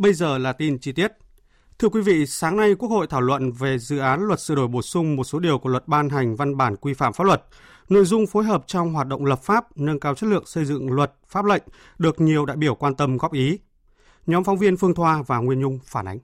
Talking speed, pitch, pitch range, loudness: 265 wpm, 150 Hz, 135-185 Hz, -21 LUFS